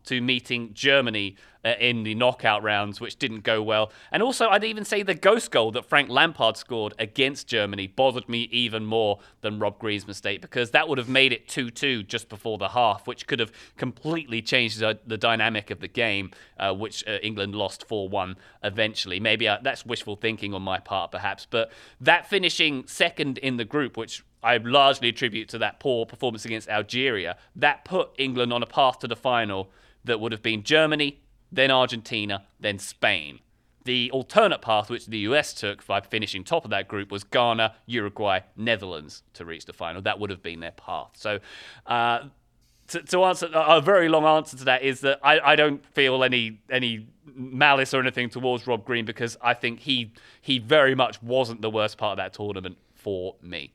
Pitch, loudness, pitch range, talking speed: 120 Hz, -24 LUFS, 105-135 Hz, 195 wpm